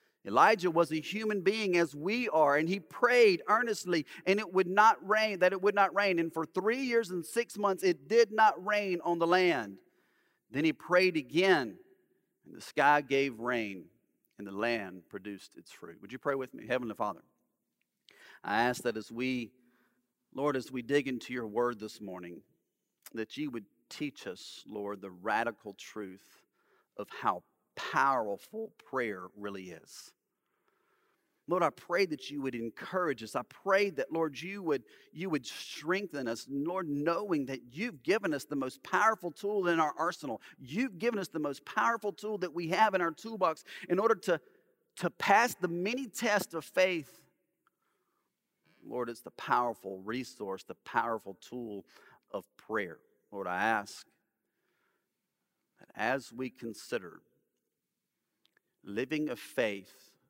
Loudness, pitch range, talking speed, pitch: -32 LUFS, 125-205 Hz, 160 wpm, 165 Hz